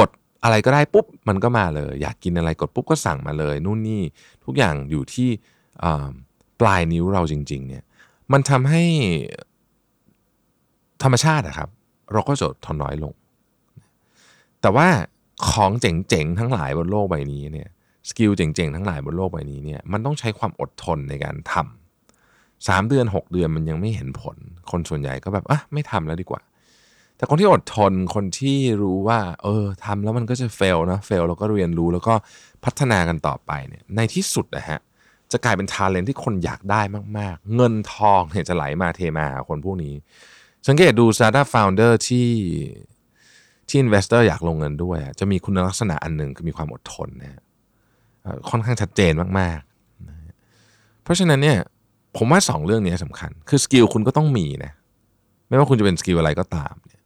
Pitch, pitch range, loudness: 100 Hz, 85-120 Hz, -20 LUFS